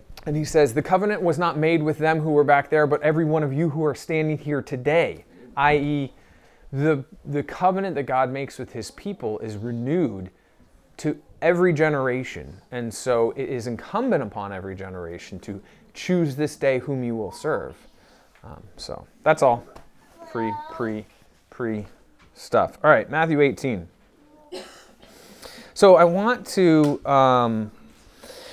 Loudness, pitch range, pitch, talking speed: -22 LUFS, 120-160 Hz, 145 Hz, 150 wpm